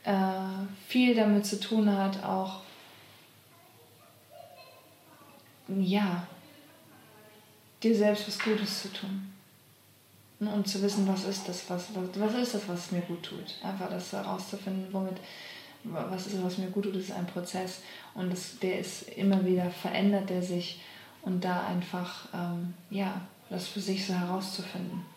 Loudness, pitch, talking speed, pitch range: -32 LUFS, 190 Hz, 145 wpm, 180-200 Hz